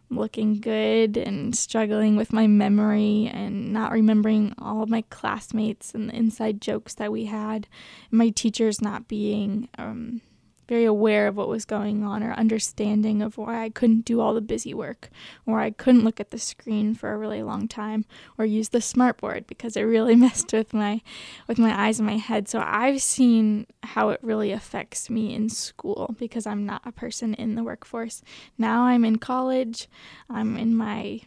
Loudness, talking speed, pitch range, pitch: -24 LUFS, 190 wpm, 215-230 Hz, 220 Hz